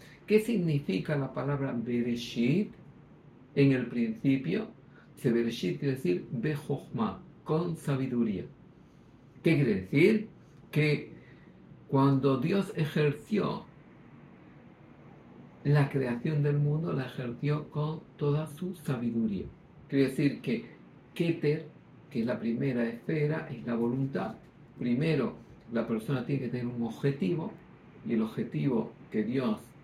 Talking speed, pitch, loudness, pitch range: 115 wpm, 140 Hz, -31 LUFS, 120-155 Hz